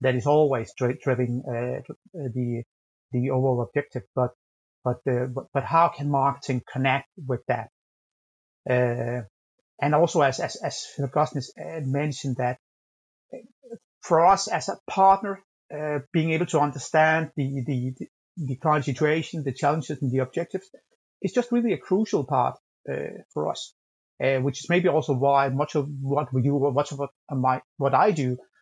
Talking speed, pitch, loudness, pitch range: 150 wpm, 140 Hz, -25 LUFS, 125-155 Hz